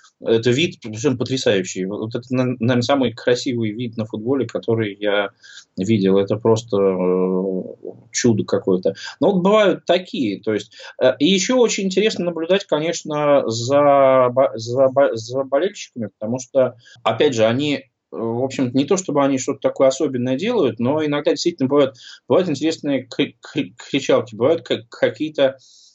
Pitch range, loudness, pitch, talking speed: 115-150 Hz, -19 LUFS, 130 Hz, 135 wpm